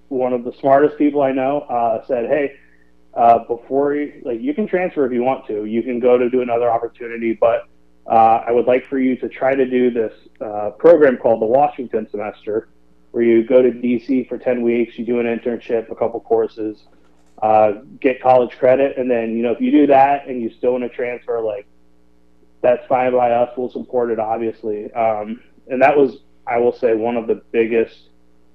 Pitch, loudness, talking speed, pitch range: 120 Hz, -17 LUFS, 210 wpm, 110-130 Hz